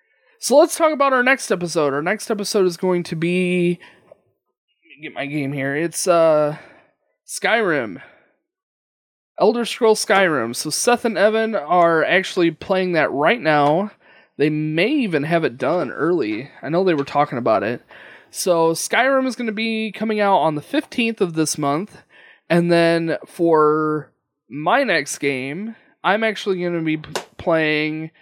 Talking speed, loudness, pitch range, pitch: 165 wpm, -19 LUFS, 155-220 Hz, 175 Hz